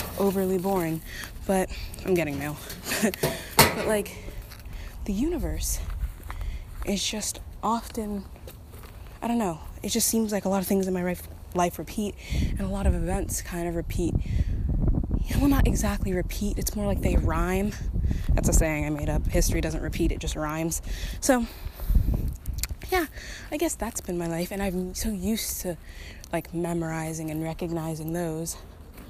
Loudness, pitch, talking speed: -28 LUFS, 170 Hz, 160 wpm